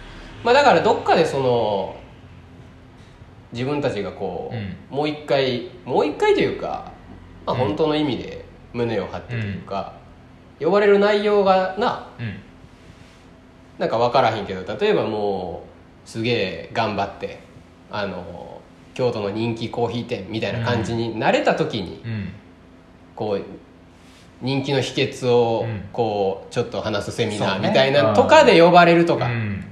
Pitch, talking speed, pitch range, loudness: 115 Hz, 265 characters per minute, 100-135 Hz, -20 LUFS